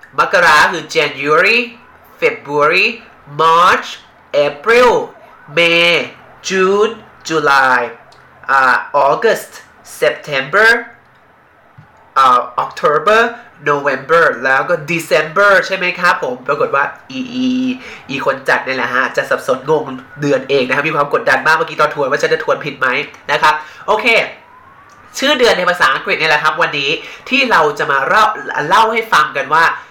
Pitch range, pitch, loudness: 150-240 Hz, 200 Hz, -13 LUFS